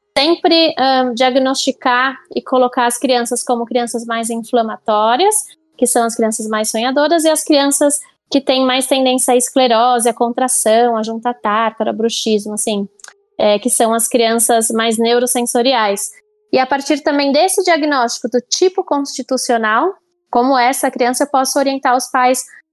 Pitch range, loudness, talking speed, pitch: 235-280 Hz, -14 LUFS, 150 wpm, 255 Hz